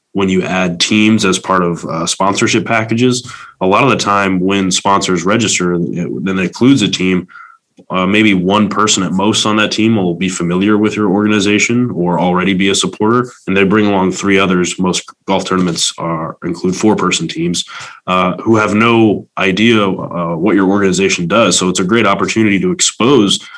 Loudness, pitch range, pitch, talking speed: -12 LUFS, 95-110 Hz, 100 Hz, 190 wpm